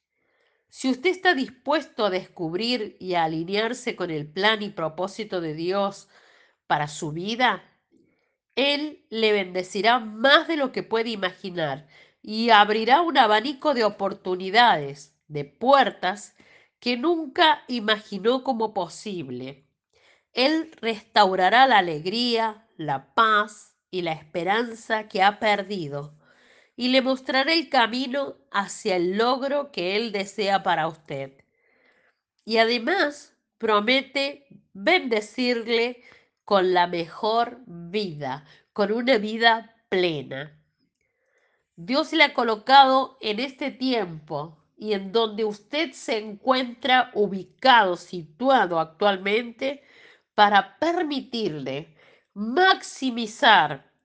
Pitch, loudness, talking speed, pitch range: 215 Hz, -23 LUFS, 110 wpm, 185-260 Hz